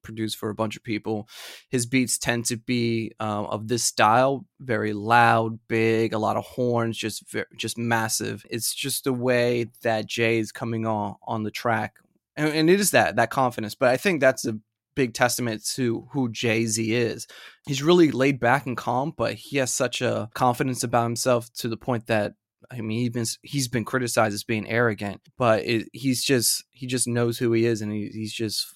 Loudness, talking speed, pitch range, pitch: -24 LUFS, 205 wpm, 110-125 Hz, 115 Hz